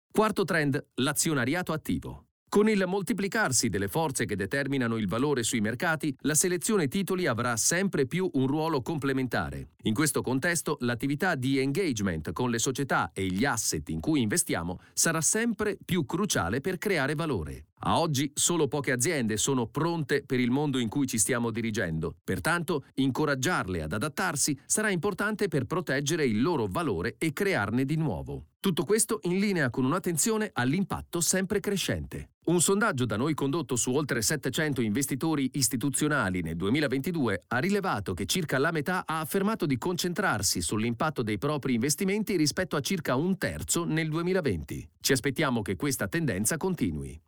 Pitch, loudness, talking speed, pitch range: 145 Hz, -28 LUFS, 155 wpm, 125-180 Hz